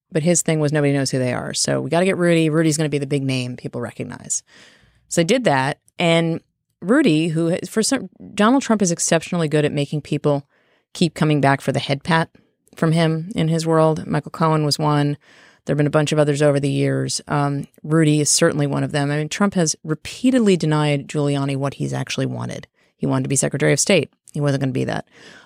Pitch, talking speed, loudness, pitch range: 150 Hz, 230 wpm, -19 LUFS, 140-165 Hz